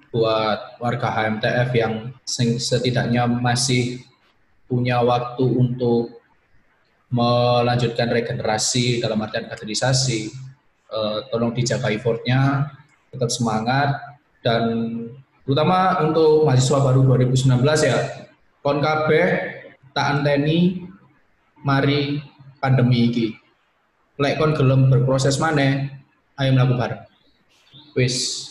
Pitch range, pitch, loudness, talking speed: 120-140 Hz, 125 Hz, -20 LUFS, 80 wpm